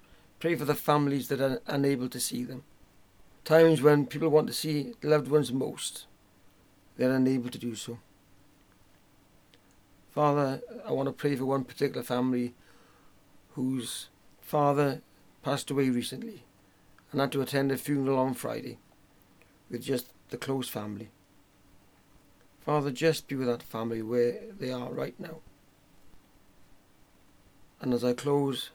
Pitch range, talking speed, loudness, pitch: 100-140 Hz, 140 wpm, -29 LUFS, 125 Hz